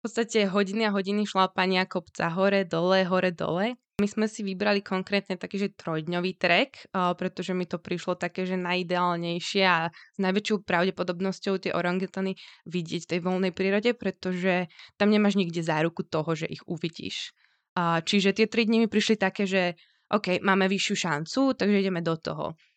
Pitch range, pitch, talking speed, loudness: 180-200 Hz, 190 Hz, 165 wpm, -27 LUFS